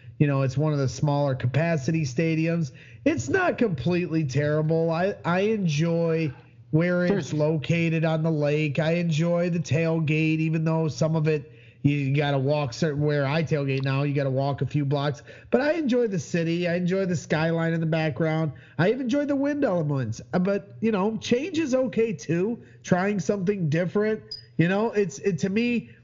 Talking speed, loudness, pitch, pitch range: 185 wpm, -25 LUFS, 160 Hz, 145-185 Hz